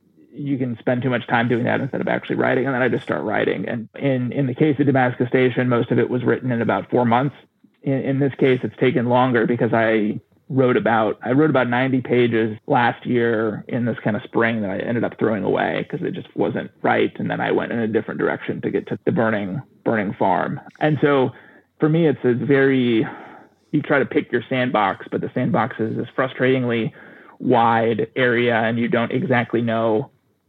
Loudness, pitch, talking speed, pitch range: -20 LUFS, 120 Hz, 215 wpm, 115-130 Hz